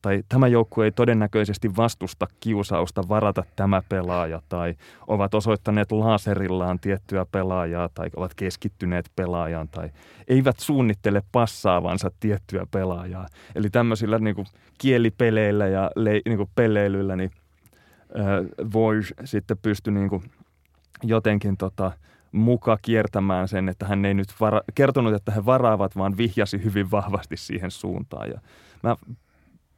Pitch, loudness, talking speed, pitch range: 100 Hz, -24 LUFS, 125 wpm, 95-110 Hz